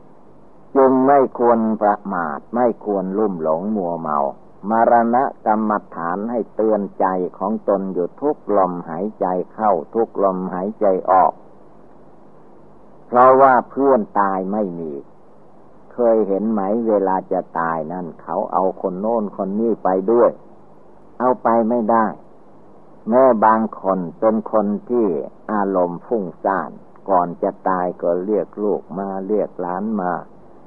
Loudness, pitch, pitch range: -19 LUFS, 105 Hz, 95-115 Hz